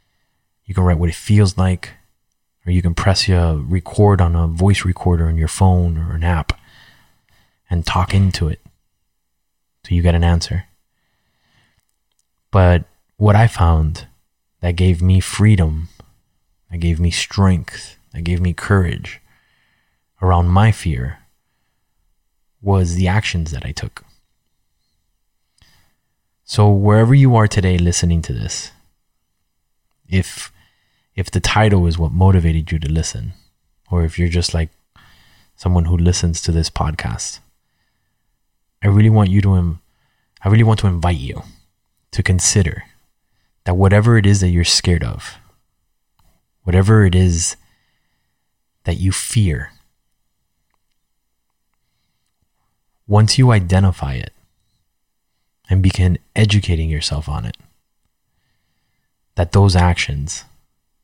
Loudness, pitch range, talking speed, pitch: -16 LUFS, 85-100 Hz, 125 wpm, 90 Hz